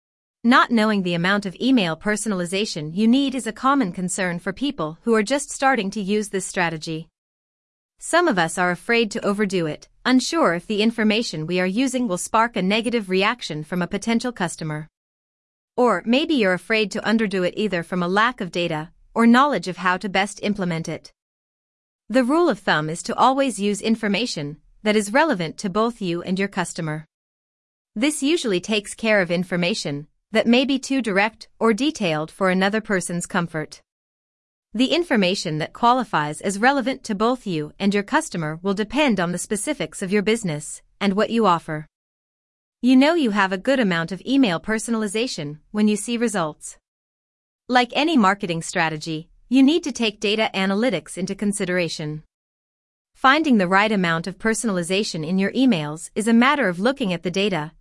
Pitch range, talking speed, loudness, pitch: 175-235 Hz, 175 wpm, -21 LUFS, 205 Hz